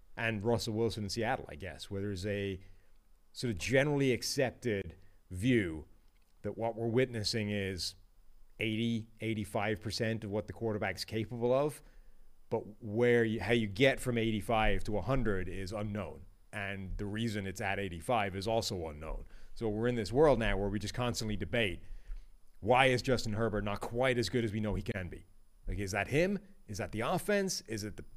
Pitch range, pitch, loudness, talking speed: 100-115 Hz, 110 Hz, -34 LUFS, 185 wpm